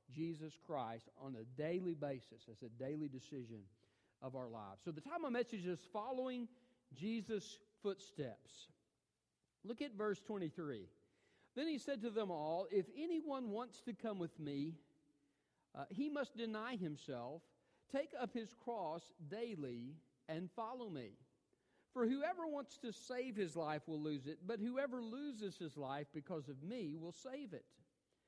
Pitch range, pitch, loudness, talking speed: 145-235 Hz, 180 Hz, -46 LUFS, 155 wpm